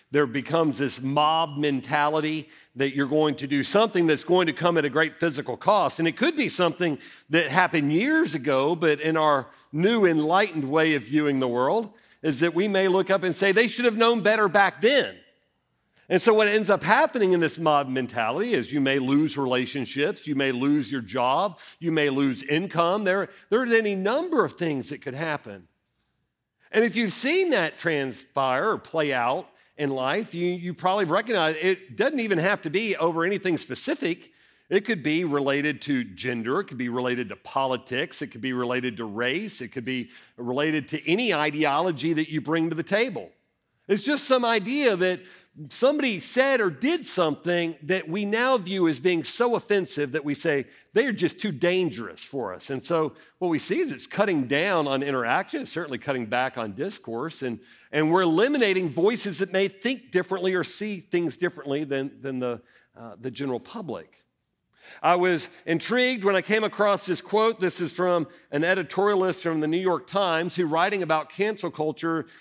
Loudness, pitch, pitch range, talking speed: -24 LUFS, 165 Hz, 145-195 Hz, 190 wpm